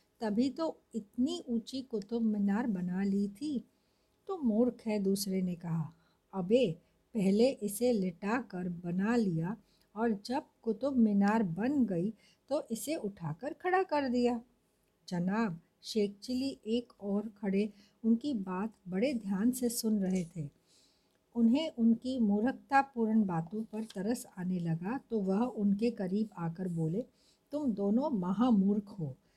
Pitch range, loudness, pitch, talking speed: 195-245 Hz, -33 LUFS, 220 Hz, 135 wpm